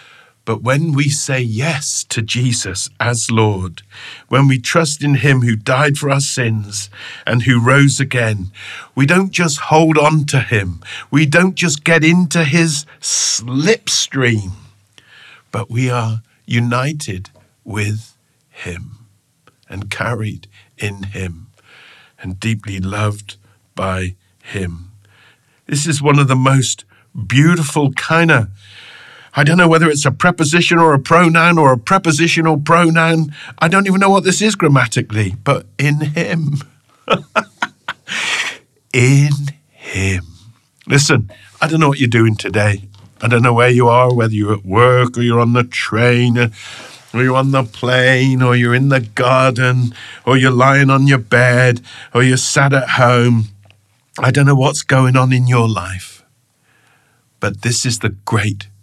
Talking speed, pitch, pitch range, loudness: 150 wpm, 125 Hz, 110-145 Hz, -14 LUFS